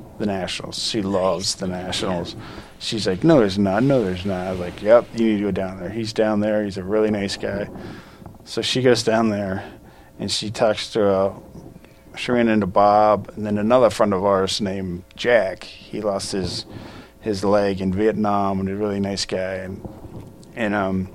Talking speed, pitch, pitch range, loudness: 195 wpm, 100 Hz, 95-110 Hz, -21 LUFS